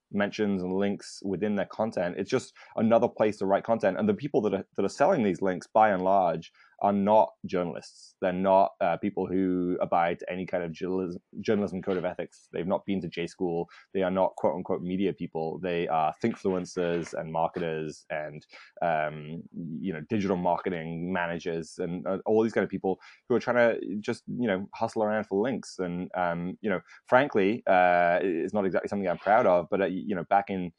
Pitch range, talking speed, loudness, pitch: 85-100 Hz, 205 wpm, -28 LUFS, 90 Hz